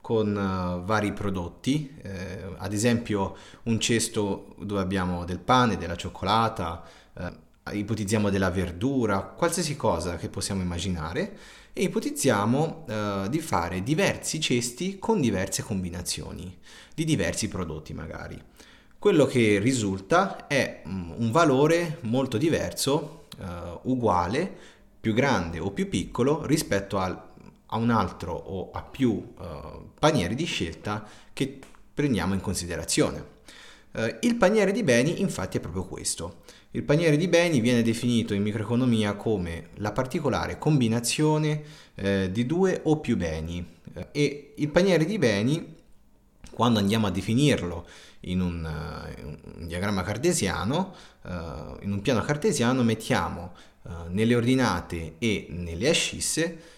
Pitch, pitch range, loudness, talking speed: 105 Hz, 90-130 Hz, -26 LUFS, 130 wpm